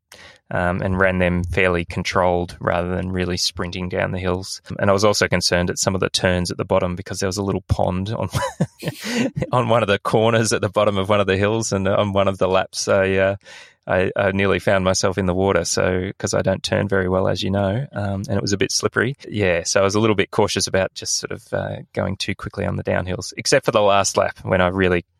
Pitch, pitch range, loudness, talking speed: 95 Hz, 90-100 Hz, -20 LUFS, 250 wpm